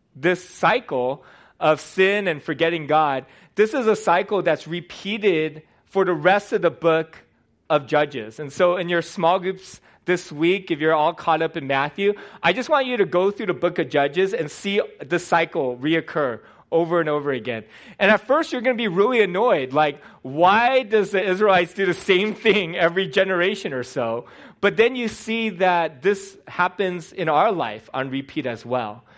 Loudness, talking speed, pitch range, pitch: -21 LUFS, 190 wpm, 155-200 Hz, 175 Hz